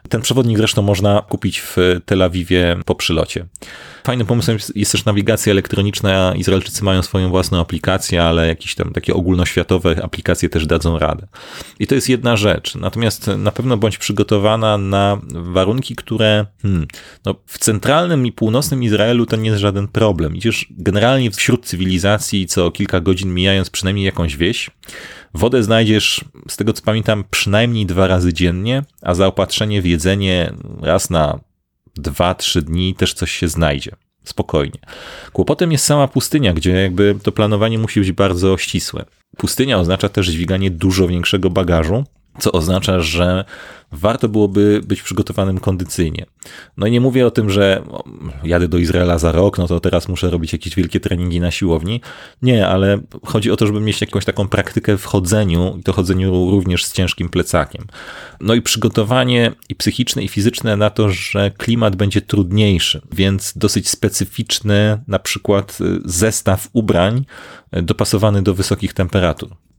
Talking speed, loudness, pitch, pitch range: 155 wpm, -16 LUFS, 100 Hz, 90-110 Hz